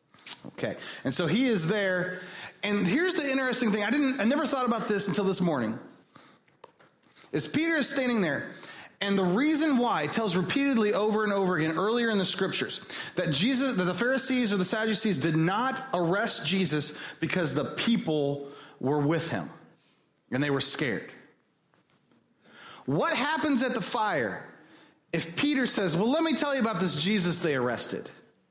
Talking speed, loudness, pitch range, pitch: 170 wpm, -27 LUFS, 180-255 Hz, 205 Hz